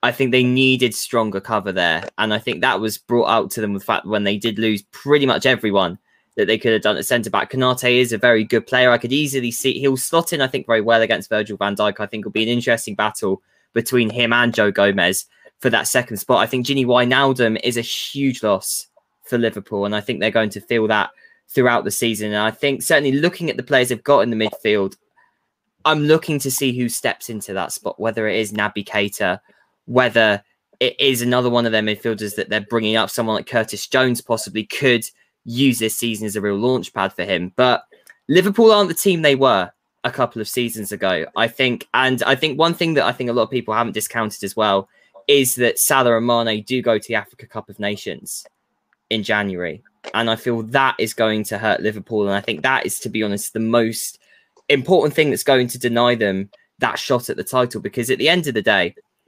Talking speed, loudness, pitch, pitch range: 235 wpm, -18 LUFS, 115 Hz, 110-130 Hz